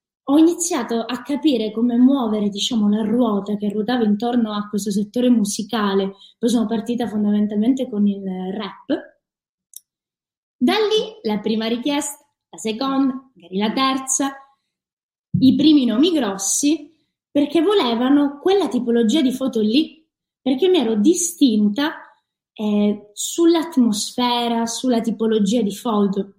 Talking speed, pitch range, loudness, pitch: 125 wpm, 210-285 Hz, -19 LUFS, 240 Hz